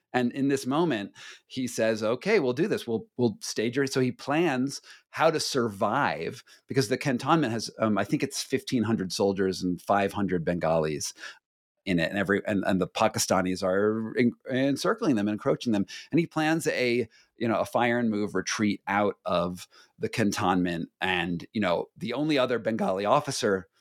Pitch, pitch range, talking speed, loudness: 110 Hz, 95-130 Hz, 175 wpm, -27 LUFS